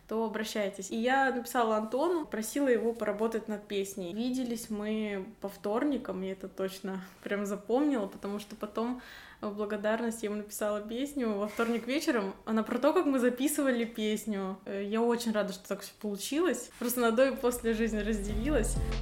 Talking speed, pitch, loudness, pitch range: 165 wpm, 220 Hz, -32 LUFS, 205-245 Hz